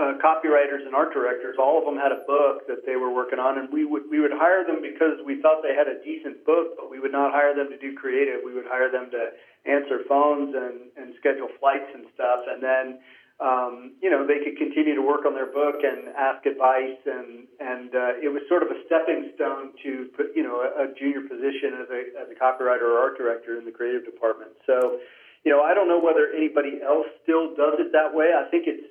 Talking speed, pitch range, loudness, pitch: 240 wpm, 130-155 Hz, -24 LUFS, 140 Hz